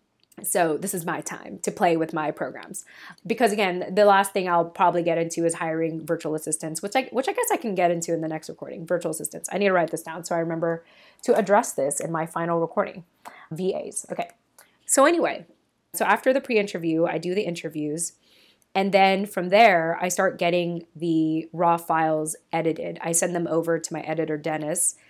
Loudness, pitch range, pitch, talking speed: -24 LUFS, 160-195 Hz, 170 Hz, 205 wpm